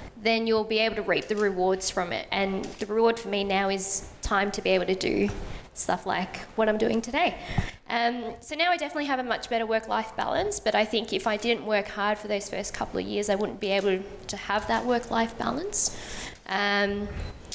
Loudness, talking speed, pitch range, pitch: -27 LUFS, 225 wpm, 200-230 Hz, 215 Hz